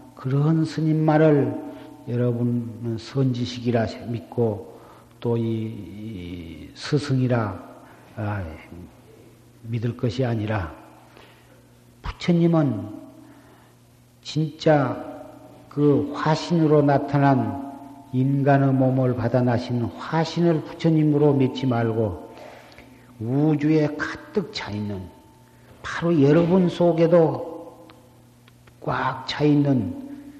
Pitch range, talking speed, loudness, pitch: 115-150 Hz, 170 characters per minute, -22 LUFS, 130 Hz